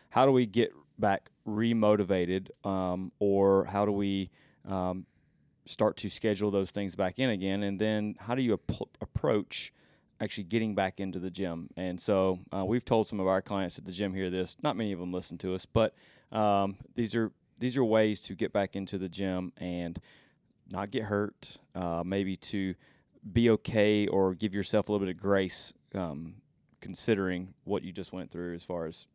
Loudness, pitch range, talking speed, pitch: -31 LUFS, 95-105 Hz, 195 wpm, 100 Hz